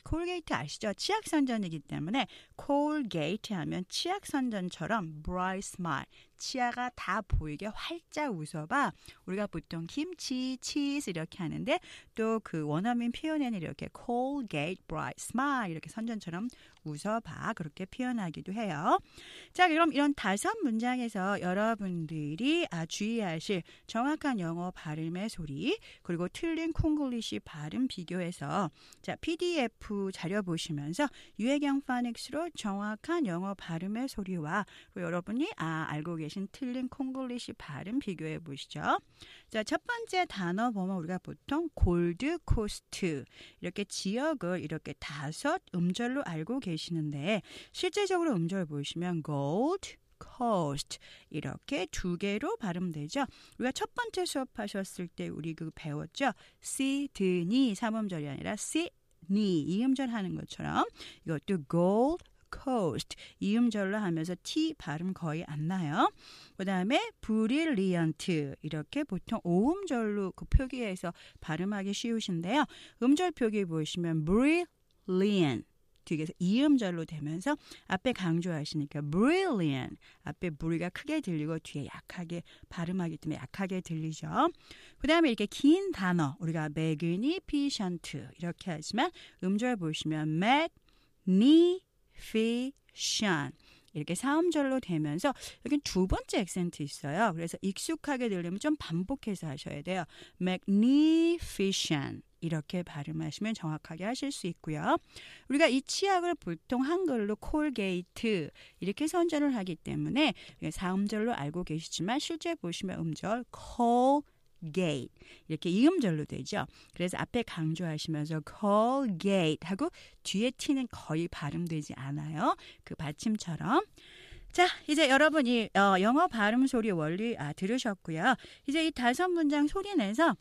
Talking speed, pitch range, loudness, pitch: 310 characters per minute, 165-275 Hz, -32 LUFS, 200 Hz